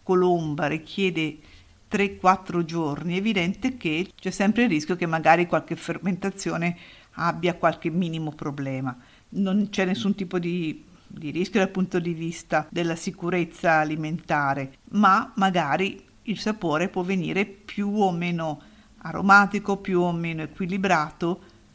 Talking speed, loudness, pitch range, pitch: 130 wpm, -25 LUFS, 160-195 Hz, 175 Hz